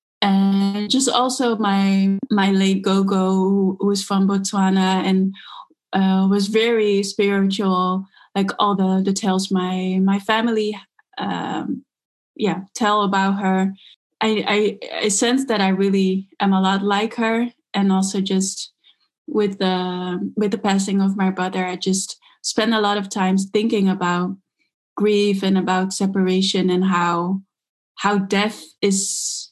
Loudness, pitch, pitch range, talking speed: -19 LUFS, 195 Hz, 190-205 Hz, 140 wpm